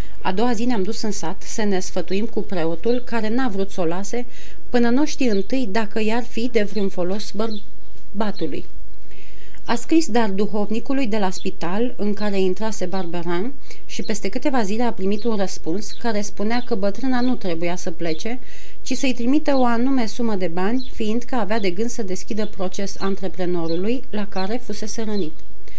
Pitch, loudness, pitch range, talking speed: 215 Hz, -24 LUFS, 190-235 Hz, 180 wpm